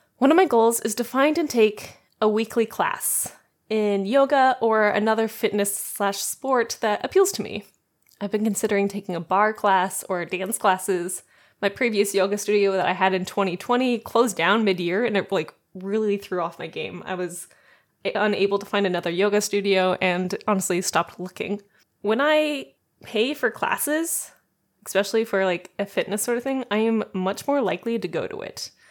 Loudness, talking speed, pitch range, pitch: -23 LUFS, 180 wpm, 190-230 Hz, 205 Hz